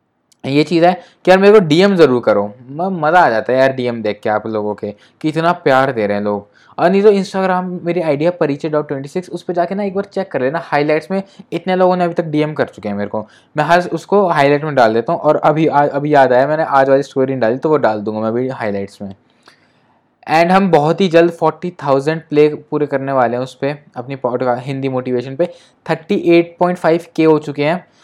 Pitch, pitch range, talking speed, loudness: 150 Hz, 130-175 Hz, 250 wpm, -15 LUFS